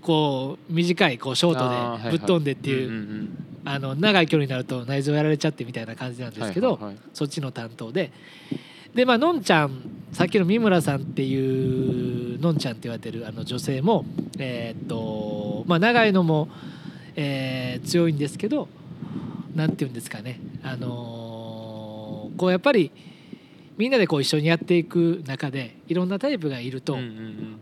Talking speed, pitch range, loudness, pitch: 345 characters per minute, 125-170 Hz, -24 LUFS, 145 Hz